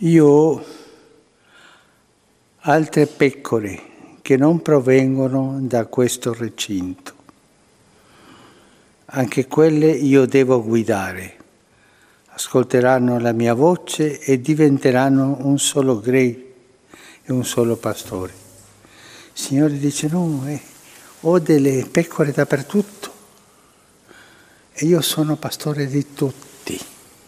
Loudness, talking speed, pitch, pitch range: -18 LUFS, 95 wpm, 135 Hz, 125-150 Hz